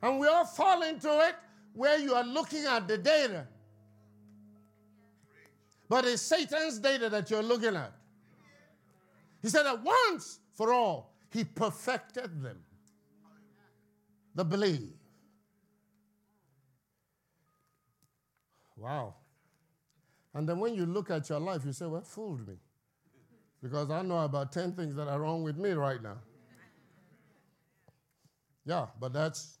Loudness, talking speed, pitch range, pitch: -32 LUFS, 130 wpm, 130-220 Hz, 160 Hz